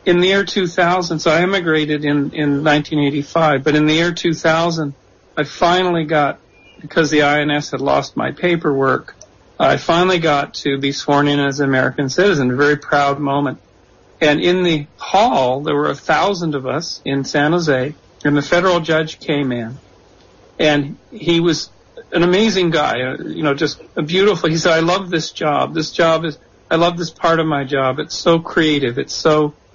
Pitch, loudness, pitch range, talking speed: 150 Hz, -16 LUFS, 140-170 Hz, 185 wpm